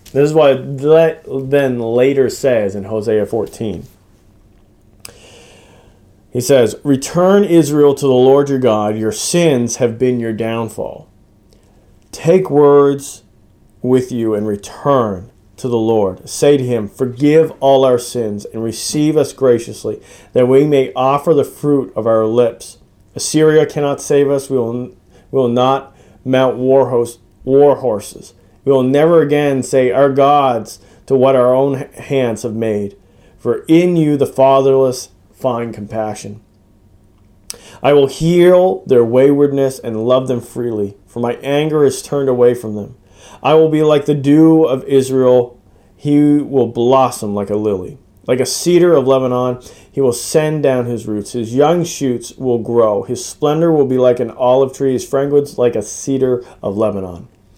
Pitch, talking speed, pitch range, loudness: 125 Hz, 155 wpm, 110-140 Hz, -14 LUFS